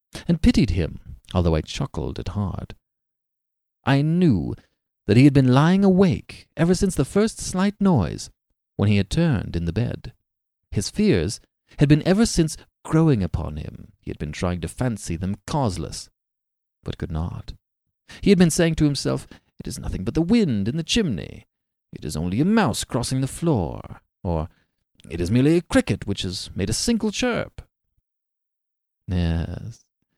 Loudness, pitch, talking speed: -22 LUFS, 120 Hz, 170 wpm